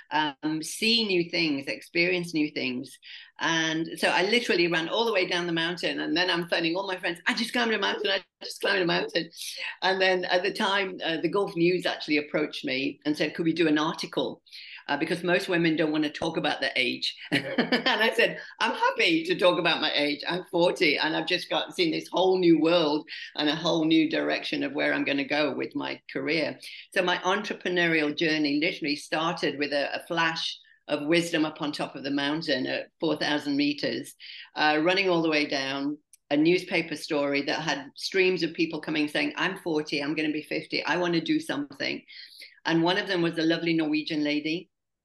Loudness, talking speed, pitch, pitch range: -26 LUFS, 210 wpm, 165 Hz, 150-185 Hz